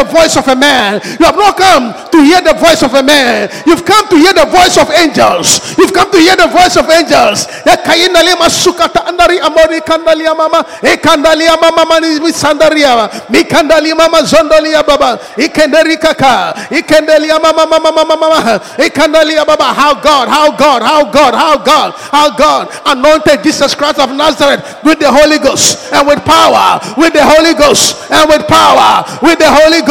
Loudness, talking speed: -6 LUFS, 145 wpm